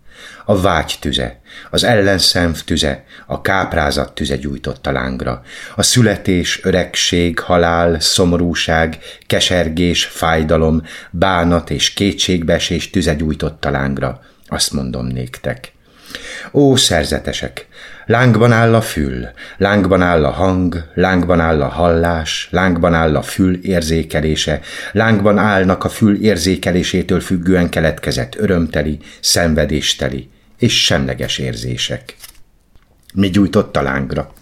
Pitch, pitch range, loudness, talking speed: 85 Hz, 75-95 Hz, -15 LUFS, 110 wpm